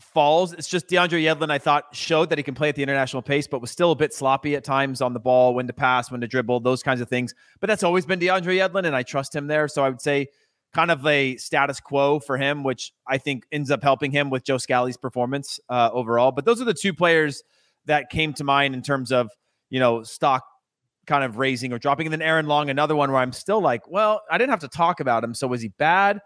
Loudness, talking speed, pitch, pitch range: -22 LUFS, 265 wpm, 140 Hz, 130-155 Hz